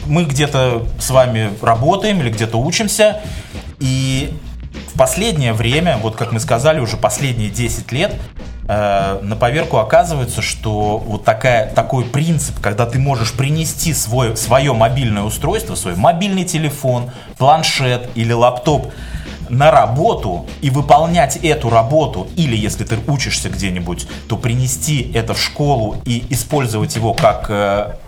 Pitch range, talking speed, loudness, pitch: 110-145 Hz, 135 wpm, -15 LUFS, 120 Hz